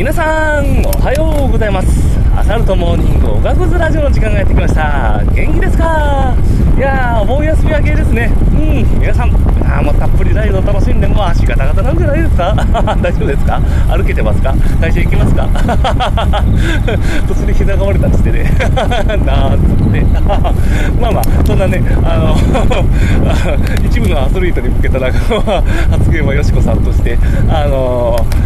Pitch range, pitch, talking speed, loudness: 85-105 Hz, 95 Hz, 345 characters per minute, -12 LUFS